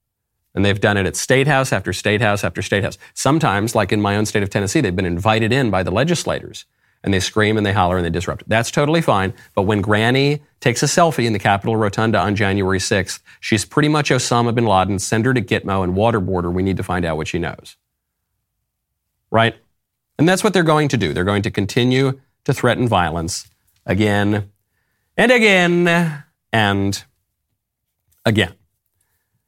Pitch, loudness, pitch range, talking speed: 105 Hz, -17 LUFS, 95-125 Hz, 195 wpm